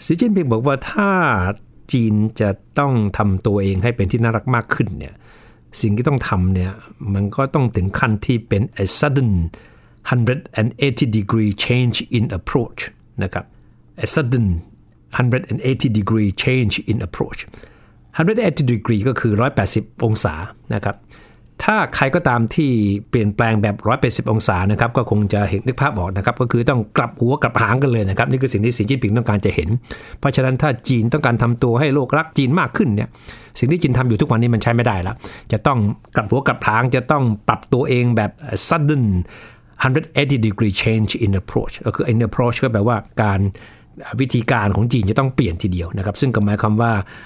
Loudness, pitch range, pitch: -18 LUFS, 105-130 Hz, 115 Hz